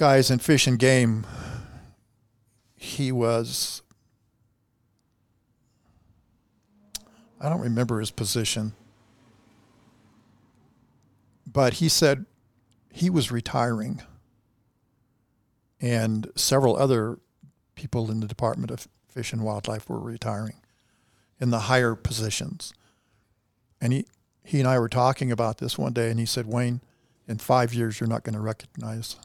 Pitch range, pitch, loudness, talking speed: 110-125 Hz, 115 Hz, -25 LUFS, 120 wpm